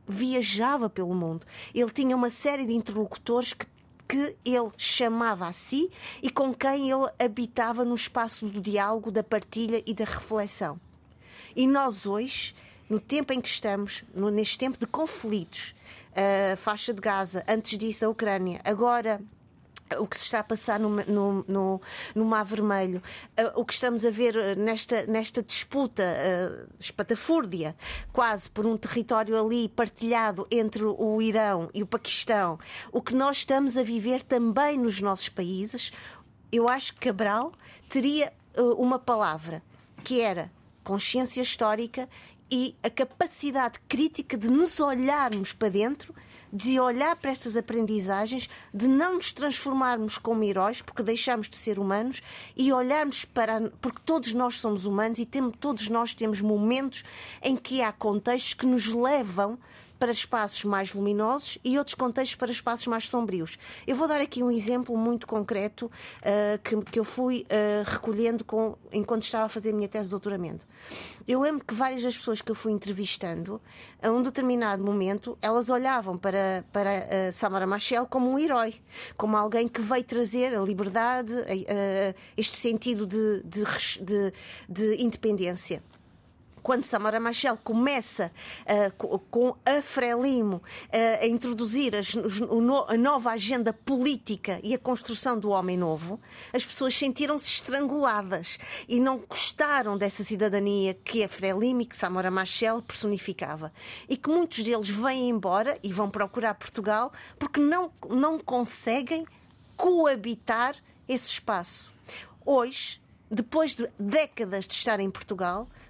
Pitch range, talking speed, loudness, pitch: 205-255 Hz, 150 wpm, -27 LUFS, 230 Hz